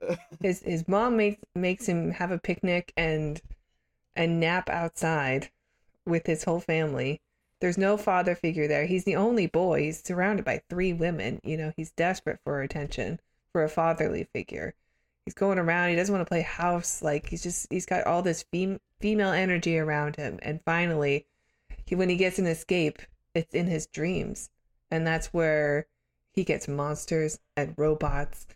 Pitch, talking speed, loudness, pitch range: 165 Hz, 170 wpm, -28 LUFS, 155-180 Hz